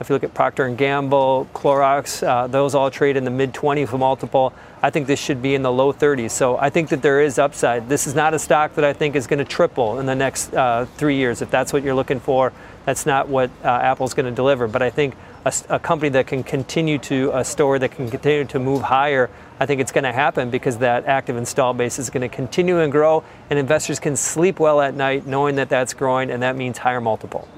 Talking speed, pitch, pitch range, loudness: 250 wpm, 135 Hz, 130-145 Hz, -19 LUFS